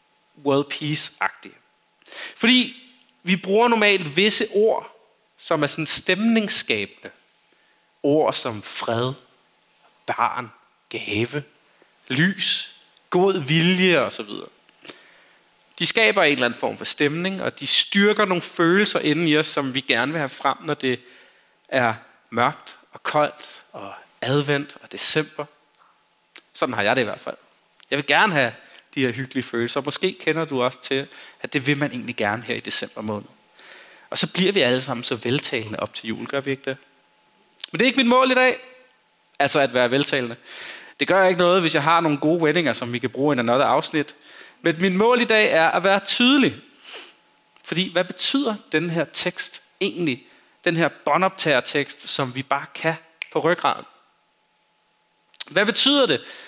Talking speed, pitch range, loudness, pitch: 170 wpm, 135-190 Hz, -21 LUFS, 155 Hz